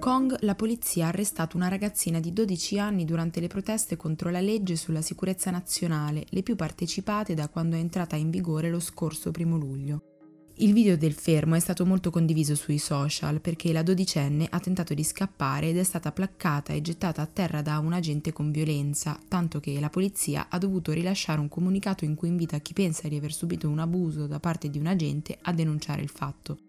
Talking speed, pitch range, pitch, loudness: 200 wpm, 155-185 Hz, 165 Hz, -28 LUFS